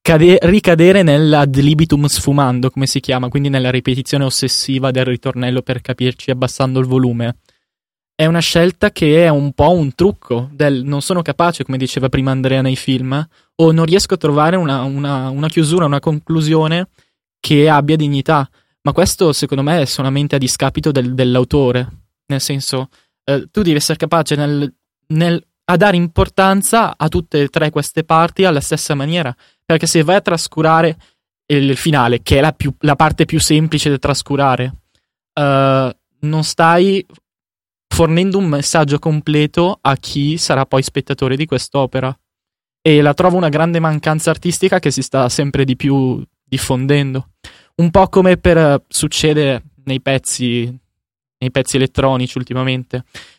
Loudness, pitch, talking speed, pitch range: -14 LUFS, 145 Hz, 155 wpm, 130-160 Hz